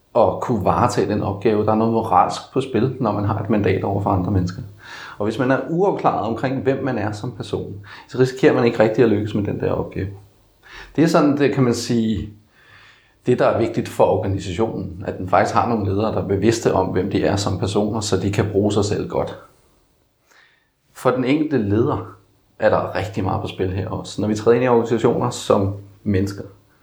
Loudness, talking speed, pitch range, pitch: -20 LUFS, 215 wpm, 95-115 Hz, 105 Hz